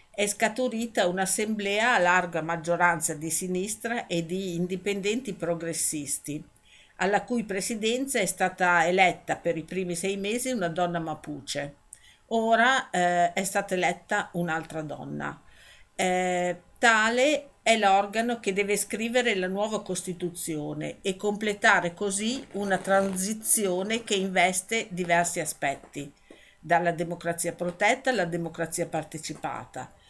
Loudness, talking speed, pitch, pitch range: -26 LUFS, 115 wpm, 185 Hz, 170-210 Hz